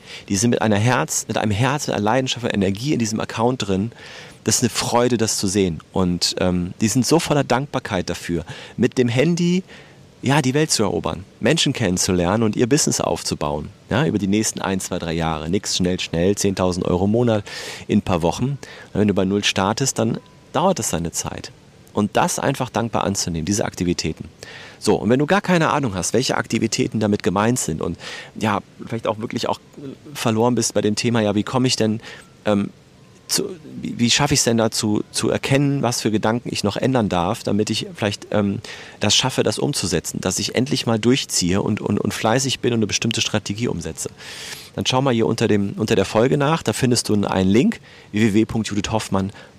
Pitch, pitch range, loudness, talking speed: 110 Hz, 100-125 Hz, -20 LUFS, 205 wpm